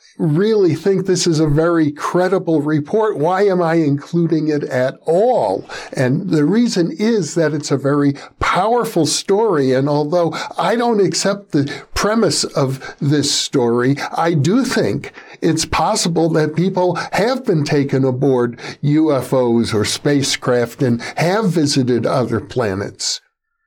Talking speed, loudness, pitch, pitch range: 135 wpm, -16 LUFS, 160 Hz, 140-185 Hz